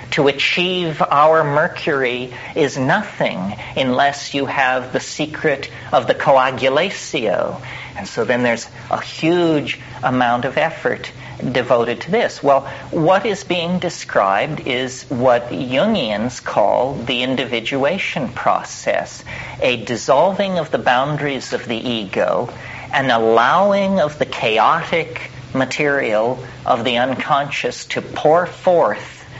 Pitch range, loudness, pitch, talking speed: 125-160 Hz, -18 LUFS, 135 Hz, 120 wpm